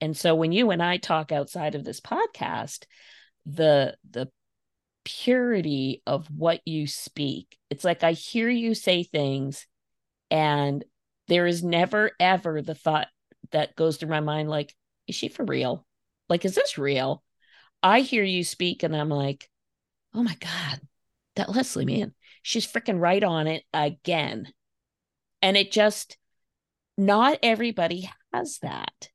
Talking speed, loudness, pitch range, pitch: 150 wpm, -25 LUFS, 145-190 Hz, 165 Hz